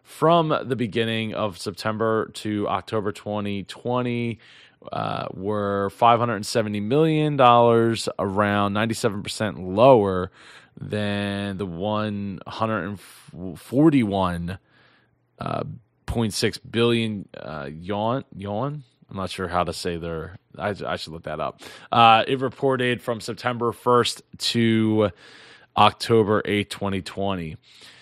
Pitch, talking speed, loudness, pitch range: 105 Hz, 95 wpm, -23 LUFS, 100-120 Hz